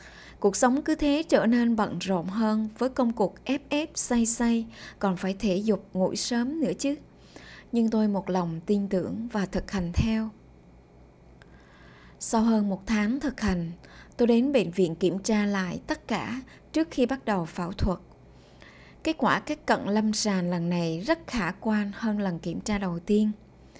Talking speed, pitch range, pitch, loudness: 185 wpm, 185-240 Hz, 210 Hz, -27 LUFS